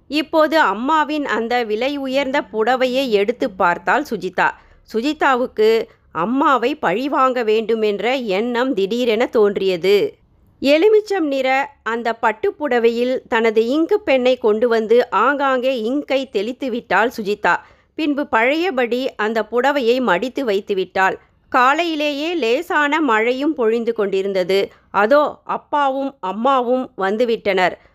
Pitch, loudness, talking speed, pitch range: 250 Hz, -18 LUFS, 100 wpm, 220-285 Hz